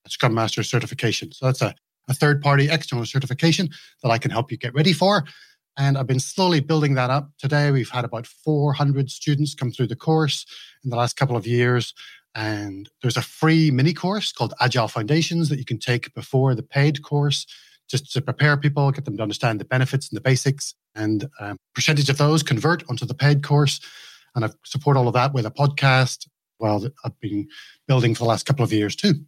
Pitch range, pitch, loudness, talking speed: 120-145 Hz, 135 Hz, -21 LUFS, 210 wpm